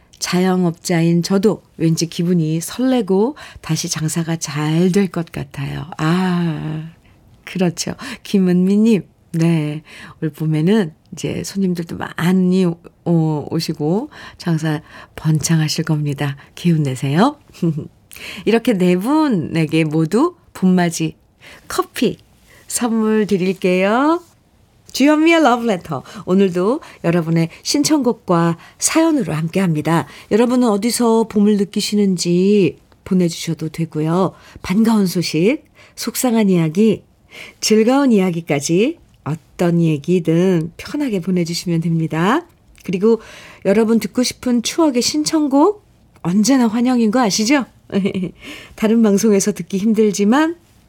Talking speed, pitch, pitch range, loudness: 245 characters per minute, 185 Hz, 165-225 Hz, -17 LUFS